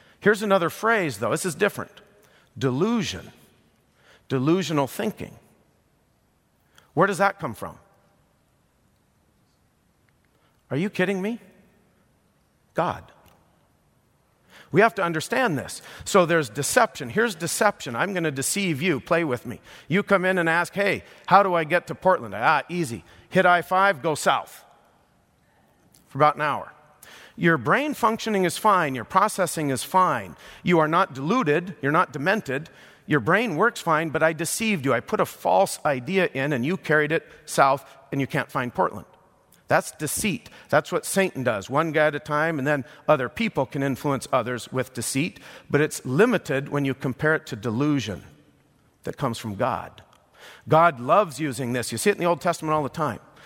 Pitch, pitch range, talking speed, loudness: 155 Hz, 135-190 Hz, 165 wpm, -23 LUFS